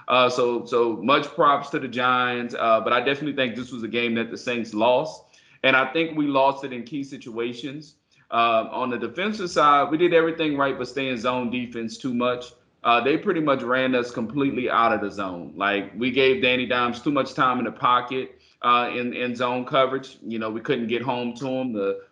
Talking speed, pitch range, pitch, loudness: 220 wpm, 120-140 Hz, 125 Hz, -23 LUFS